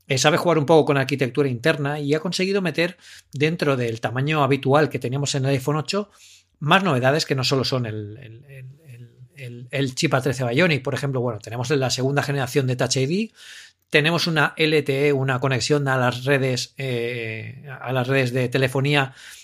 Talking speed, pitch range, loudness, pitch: 190 wpm, 130-150 Hz, -21 LUFS, 140 Hz